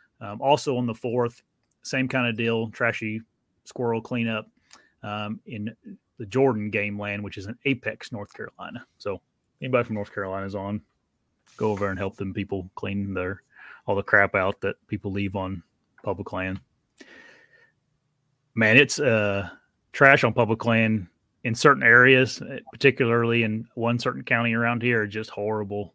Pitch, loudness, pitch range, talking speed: 110 Hz, -24 LUFS, 100-120 Hz, 155 wpm